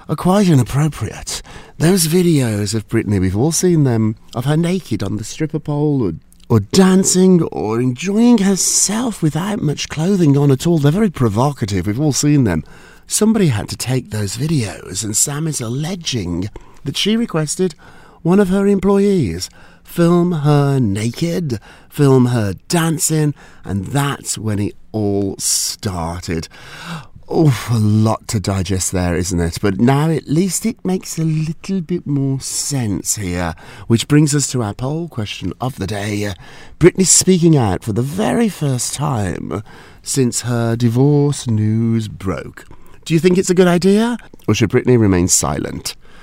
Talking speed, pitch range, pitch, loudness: 155 wpm, 105-170 Hz, 135 Hz, -16 LUFS